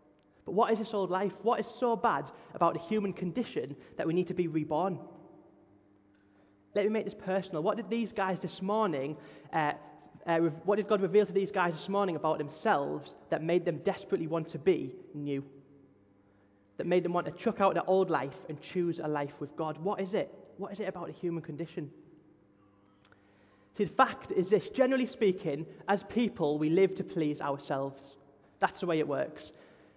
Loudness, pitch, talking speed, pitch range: -32 LUFS, 175 Hz, 195 wpm, 145-200 Hz